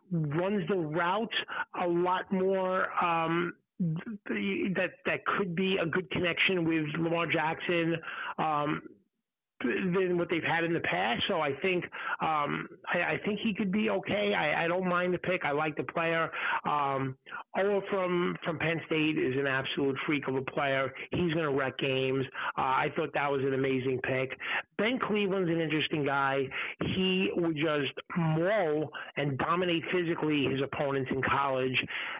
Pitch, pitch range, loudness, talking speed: 165 Hz, 145-185 Hz, -30 LUFS, 165 wpm